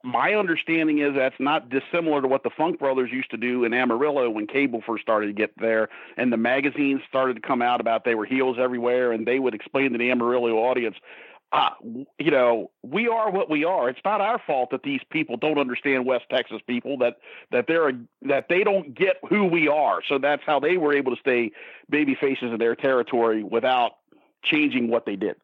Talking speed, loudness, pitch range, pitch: 225 wpm, -23 LUFS, 120-145 Hz, 130 Hz